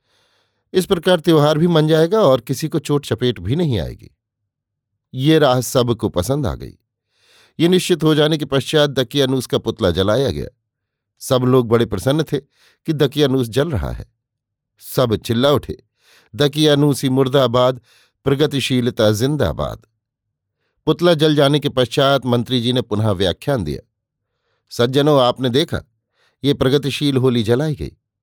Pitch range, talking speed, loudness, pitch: 115-145 Hz, 145 wpm, -17 LUFS, 130 Hz